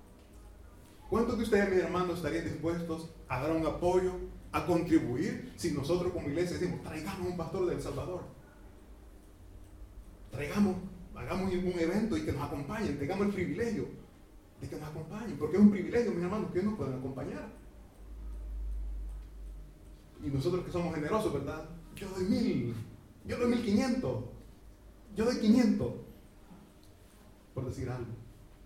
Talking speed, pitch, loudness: 140 wpm, 155 Hz, -33 LUFS